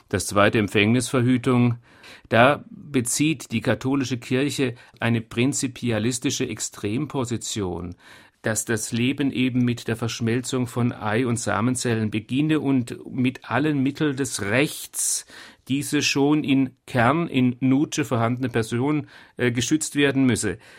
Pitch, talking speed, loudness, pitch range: 125 Hz, 115 wpm, -23 LUFS, 115-135 Hz